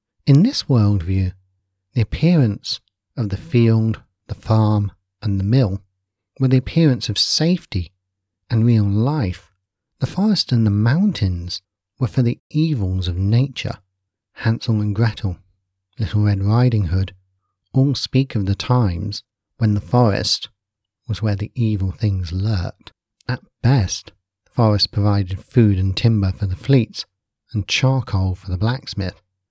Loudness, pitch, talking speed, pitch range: -19 LUFS, 105 Hz, 140 wpm, 95-120 Hz